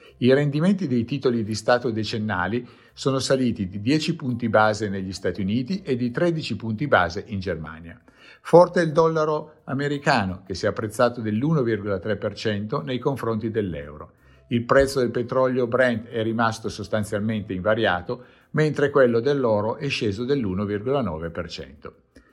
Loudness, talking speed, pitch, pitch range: -23 LUFS, 135 wpm, 115 Hz, 105-135 Hz